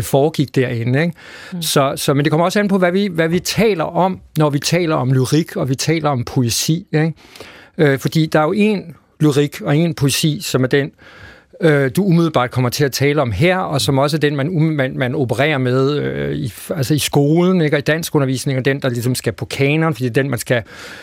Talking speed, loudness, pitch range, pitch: 235 wpm, -16 LUFS, 135-160 Hz, 145 Hz